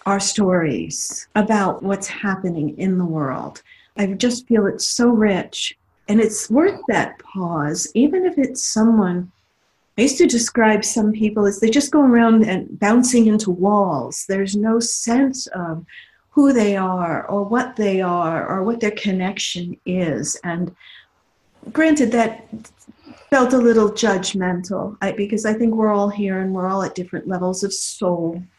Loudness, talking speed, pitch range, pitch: -19 LUFS, 160 wpm, 185-230 Hz, 205 Hz